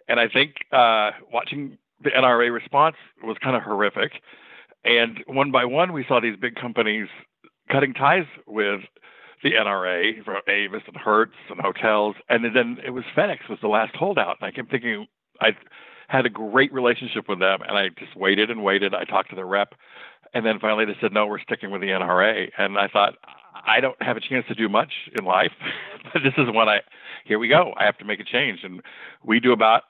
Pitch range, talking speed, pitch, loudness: 110-130 Hz, 210 wpm, 120 Hz, -22 LUFS